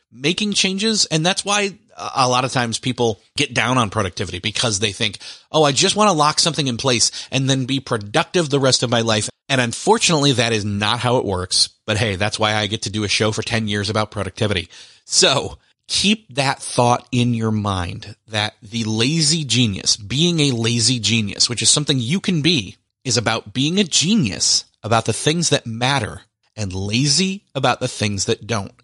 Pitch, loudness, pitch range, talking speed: 120 Hz, -18 LUFS, 110-145 Hz, 200 wpm